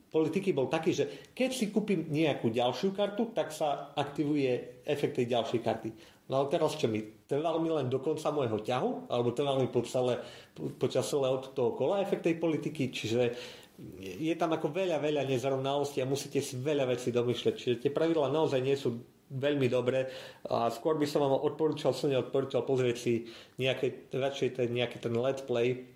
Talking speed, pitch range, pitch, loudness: 180 wpm, 125-155 Hz, 135 Hz, -31 LUFS